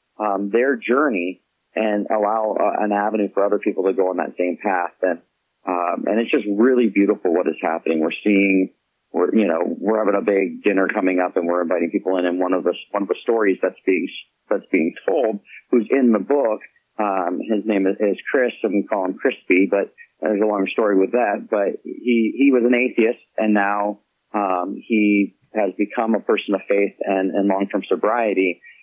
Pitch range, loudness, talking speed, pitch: 95-110 Hz, -20 LUFS, 205 wpm, 100 Hz